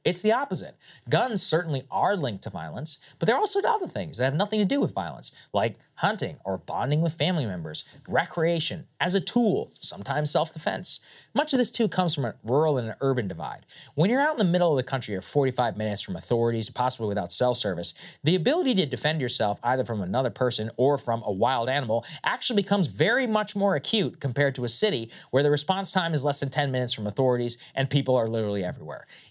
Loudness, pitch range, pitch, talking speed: -26 LUFS, 120-185 Hz, 140 Hz, 215 wpm